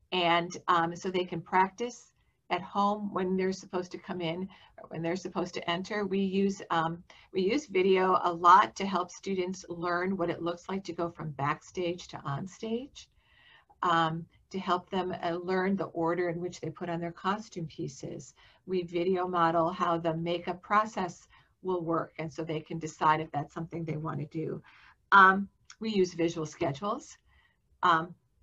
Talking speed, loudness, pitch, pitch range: 180 wpm, -30 LUFS, 175 Hz, 165-190 Hz